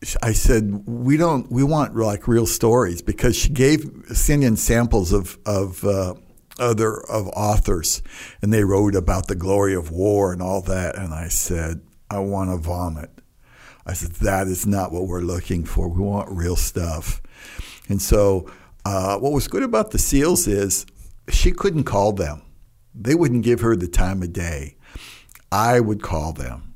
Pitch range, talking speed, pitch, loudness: 90-115 Hz, 175 wpm, 100 Hz, -21 LUFS